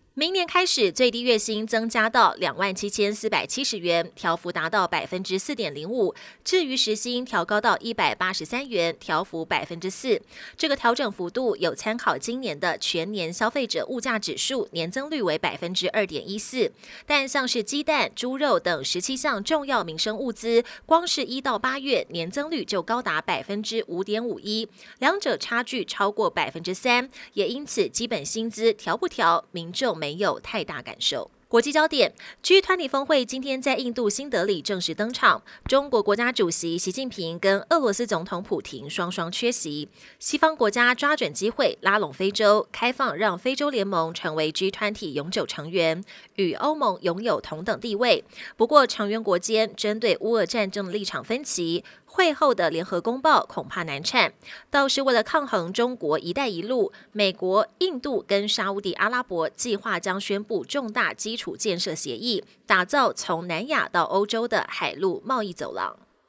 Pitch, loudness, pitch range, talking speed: 220 Hz, -24 LUFS, 185-265 Hz, 275 characters per minute